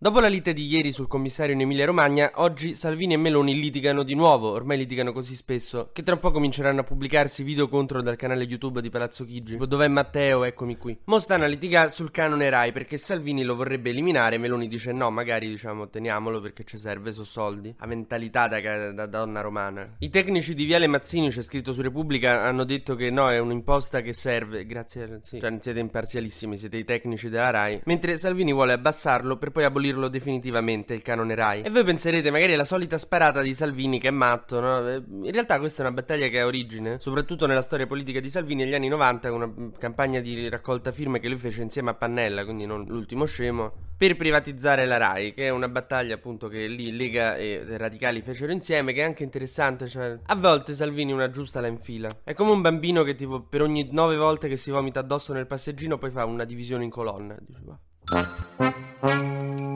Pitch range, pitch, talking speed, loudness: 115-145 Hz, 130 Hz, 205 wpm, -25 LUFS